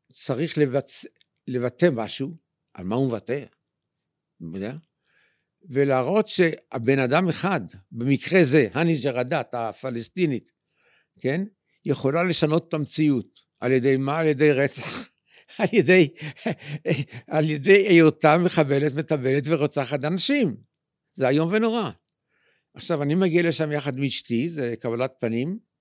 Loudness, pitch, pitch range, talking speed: -23 LUFS, 150 Hz, 130-165 Hz, 115 wpm